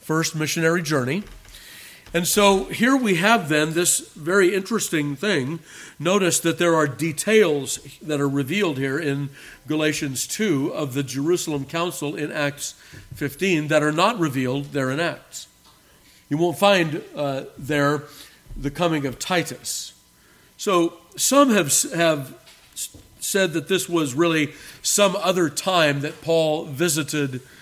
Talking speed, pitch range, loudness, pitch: 135 wpm, 145-175 Hz, -21 LUFS, 155 Hz